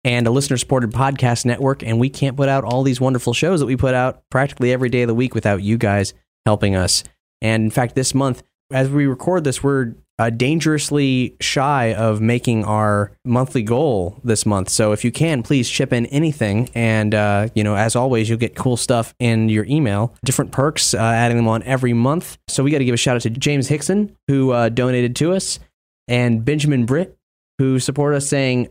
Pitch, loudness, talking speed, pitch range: 125 Hz, -18 LUFS, 210 wpm, 115-135 Hz